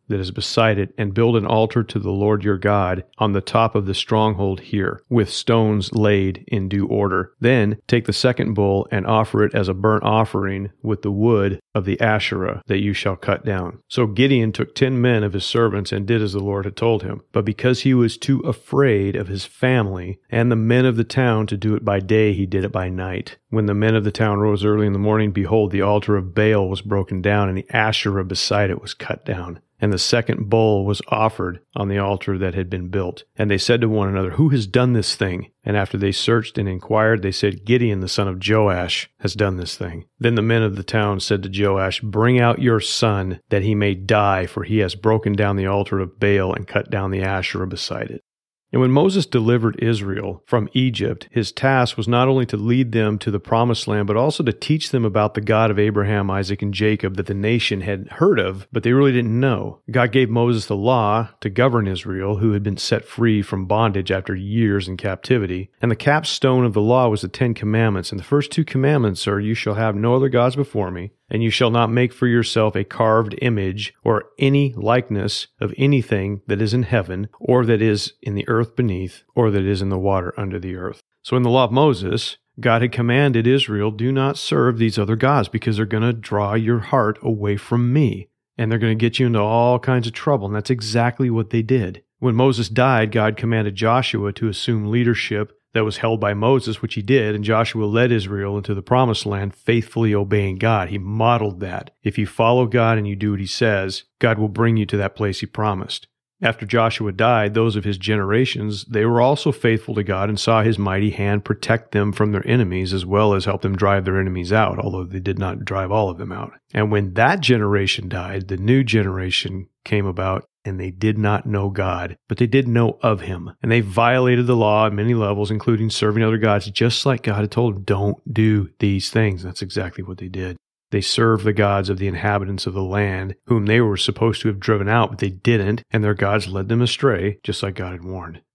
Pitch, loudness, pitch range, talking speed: 105 Hz, -19 LUFS, 100-115 Hz, 230 wpm